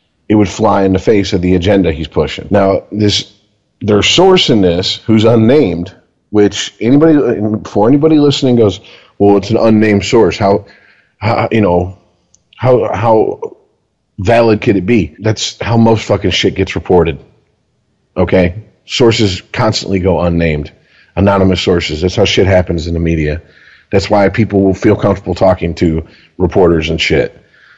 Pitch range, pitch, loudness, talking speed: 90-110 Hz, 100 Hz, -11 LUFS, 155 wpm